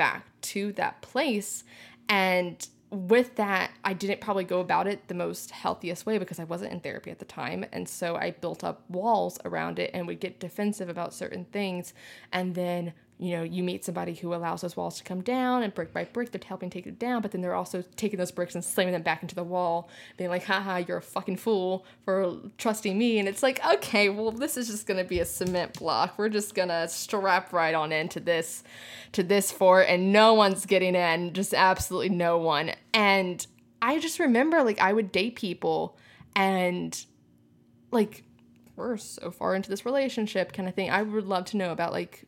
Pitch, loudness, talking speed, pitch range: 190 Hz, -28 LUFS, 210 wpm, 175-210 Hz